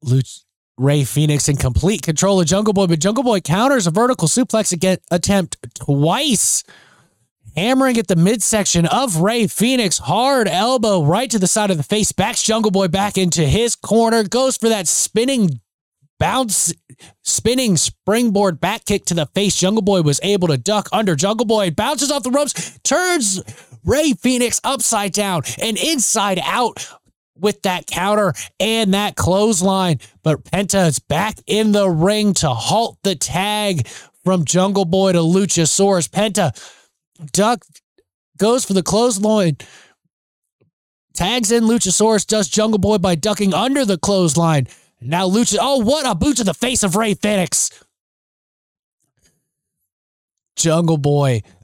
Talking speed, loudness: 145 wpm, -16 LUFS